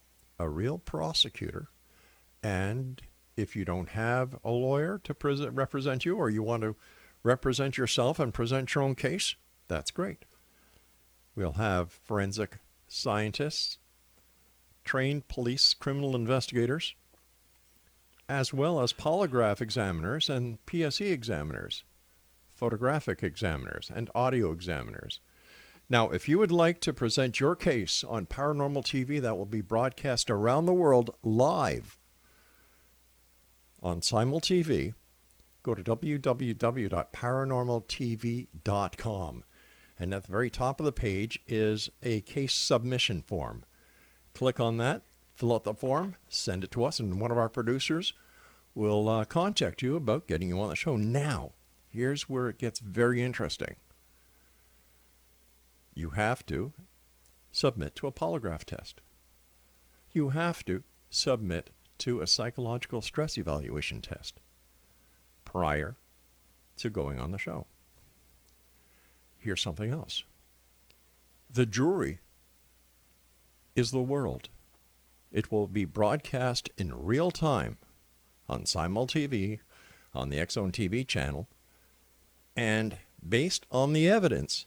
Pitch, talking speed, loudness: 110 Hz, 120 wpm, -31 LUFS